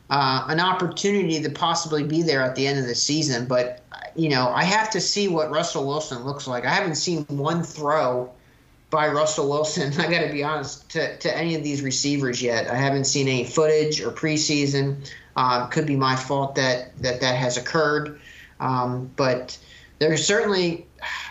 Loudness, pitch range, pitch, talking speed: -23 LUFS, 130-160 Hz, 145 Hz, 185 wpm